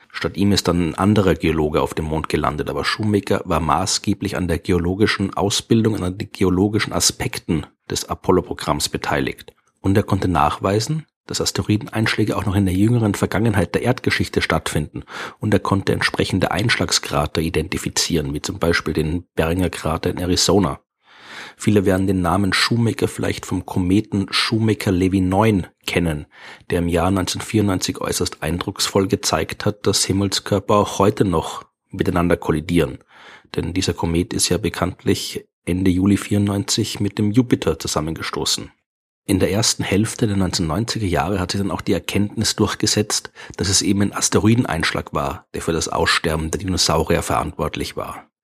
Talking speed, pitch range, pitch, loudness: 155 wpm, 90-105 Hz, 100 Hz, -19 LUFS